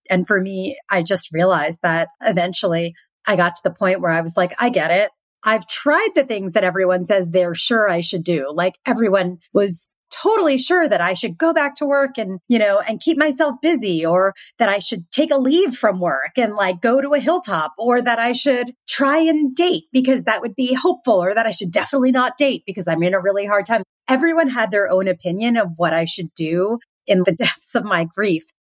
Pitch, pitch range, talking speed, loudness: 215 Hz, 185-275 Hz, 225 wpm, -18 LUFS